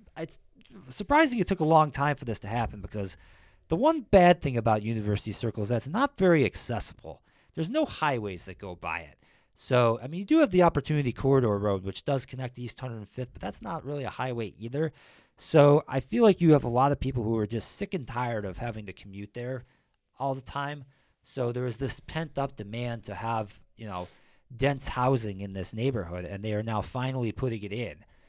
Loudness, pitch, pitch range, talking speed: -28 LUFS, 120 Hz, 105-145 Hz, 215 wpm